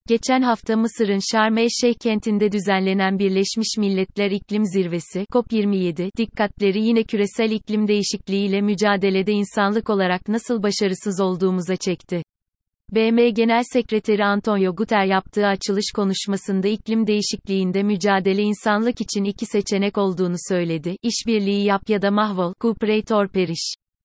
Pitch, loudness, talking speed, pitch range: 205 Hz, -21 LUFS, 120 wpm, 195-220 Hz